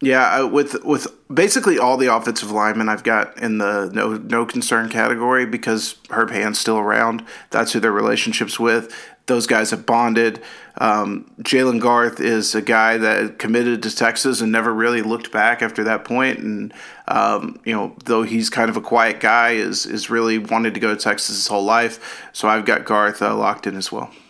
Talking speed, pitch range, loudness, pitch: 195 wpm, 110-120 Hz, -18 LUFS, 115 Hz